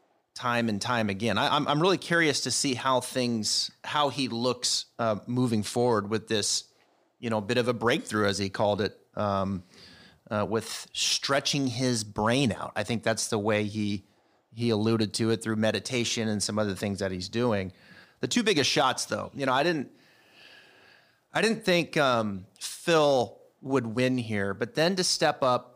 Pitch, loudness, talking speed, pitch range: 115 Hz, -27 LUFS, 185 wpm, 105-130 Hz